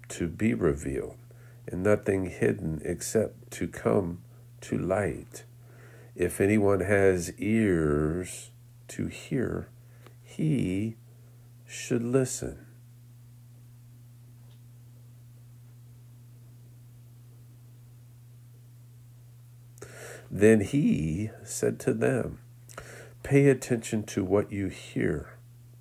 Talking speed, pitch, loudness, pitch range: 70 wpm, 120 Hz, -28 LUFS, 105-120 Hz